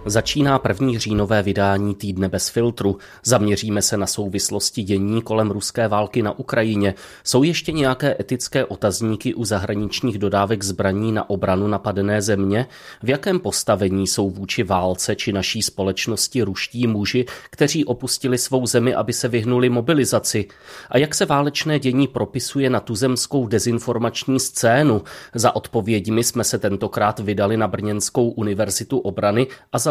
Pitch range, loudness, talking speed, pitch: 105-125 Hz, -20 LUFS, 140 wpm, 115 Hz